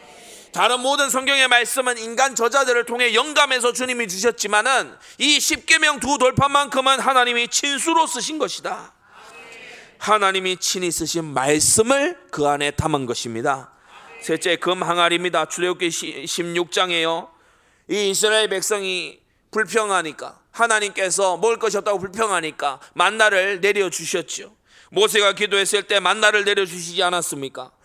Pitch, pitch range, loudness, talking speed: 205 Hz, 175-245 Hz, -19 LUFS, 310 characters per minute